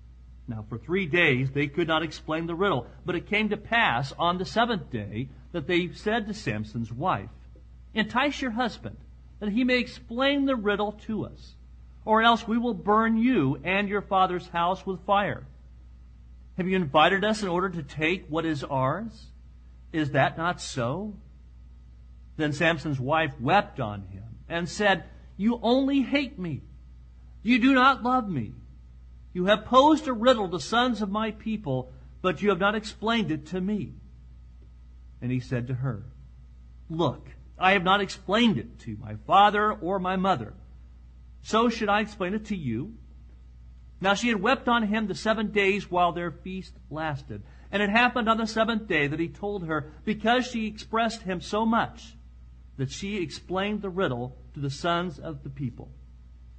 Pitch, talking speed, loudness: 175 Hz, 175 wpm, -26 LUFS